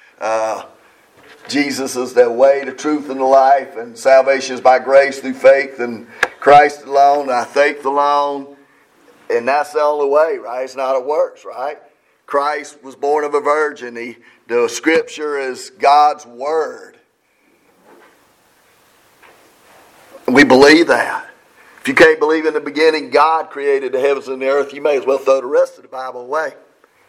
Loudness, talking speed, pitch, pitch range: -14 LUFS, 165 wpm, 140 Hz, 135-150 Hz